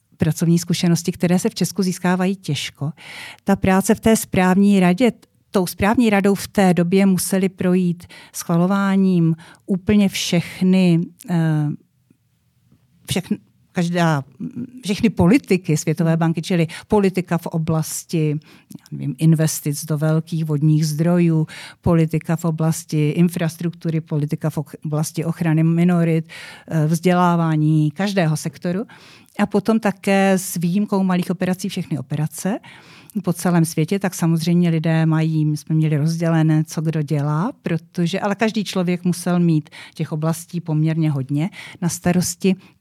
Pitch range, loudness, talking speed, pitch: 160-190 Hz, -19 LUFS, 125 wpm, 170 Hz